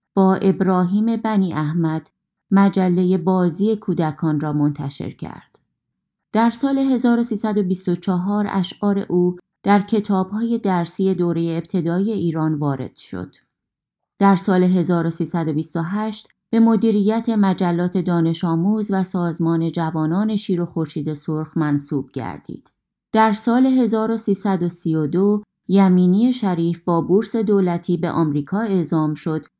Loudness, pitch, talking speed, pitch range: -19 LUFS, 185 Hz, 105 wpm, 165-205 Hz